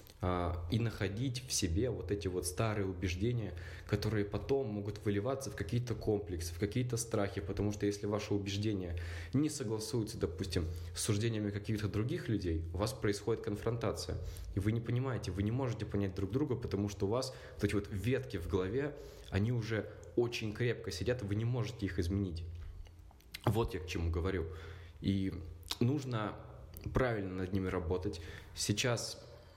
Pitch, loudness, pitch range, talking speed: 100 Hz, -37 LUFS, 95-115 Hz, 160 wpm